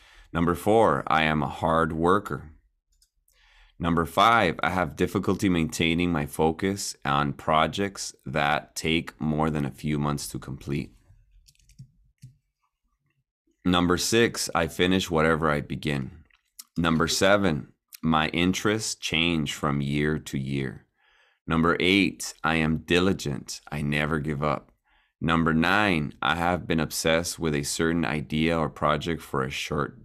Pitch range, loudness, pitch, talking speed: 75-90 Hz, -25 LUFS, 80 Hz, 130 wpm